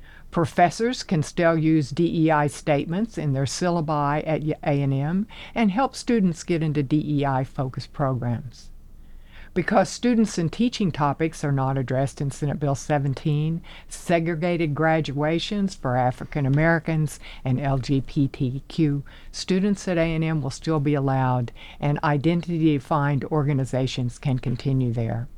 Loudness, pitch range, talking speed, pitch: -24 LUFS, 135-170 Hz, 120 wpm, 150 Hz